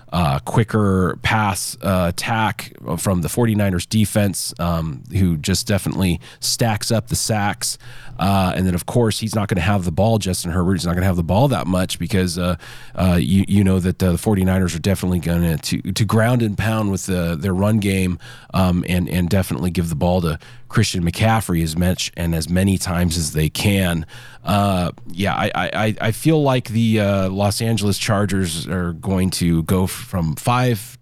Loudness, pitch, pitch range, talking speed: -19 LUFS, 95 Hz, 90-110 Hz, 195 wpm